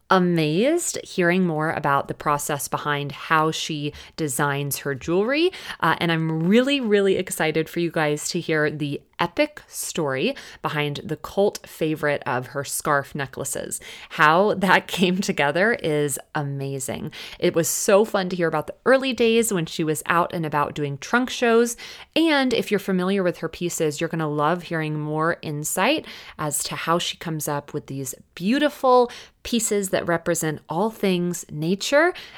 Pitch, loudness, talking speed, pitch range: 165 Hz, -22 LUFS, 165 wpm, 150-200 Hz